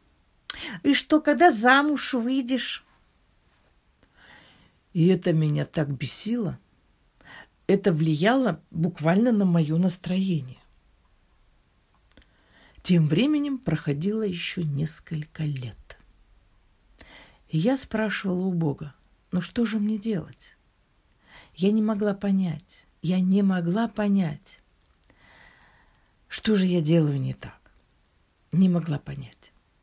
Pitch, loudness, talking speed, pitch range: 175 Hz, -24 LUFS, 100 wpm, 140-210 Hz